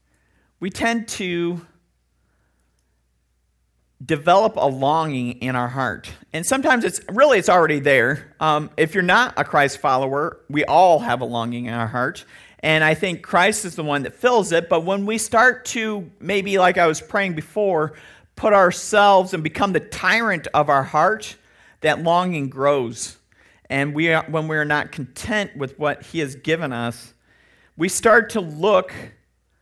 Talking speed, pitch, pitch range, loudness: 165 wpm, 155 Hz, 130-185 Hz, -19 LUFS